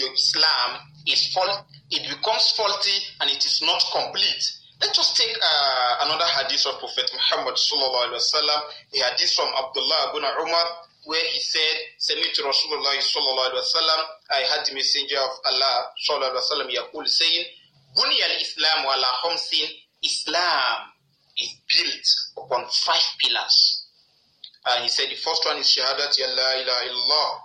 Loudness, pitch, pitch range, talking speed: -20 LUFS, 155 Hz, 135-195 Hz, 150 wpm